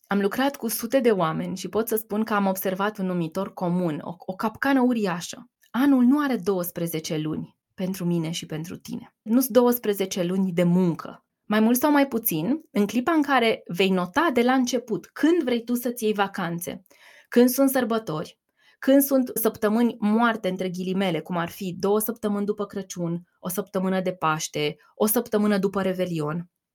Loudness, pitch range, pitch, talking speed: -24 LUFS, 185-240 Hz, 205 Hz, 180 wpm